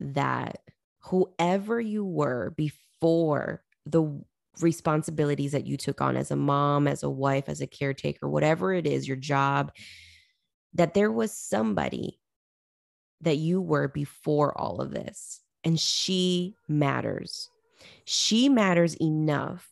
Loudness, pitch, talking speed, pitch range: -27 LUFS, 155 Hz, 130 wpm, 140-180 Hz